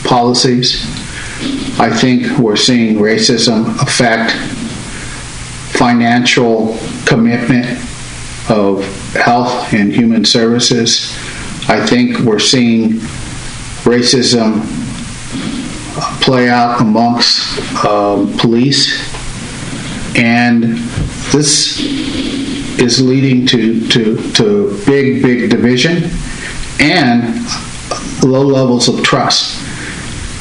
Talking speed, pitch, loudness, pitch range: 75 wpm, 120 Hz, -11 LUFS, 115-130 Hz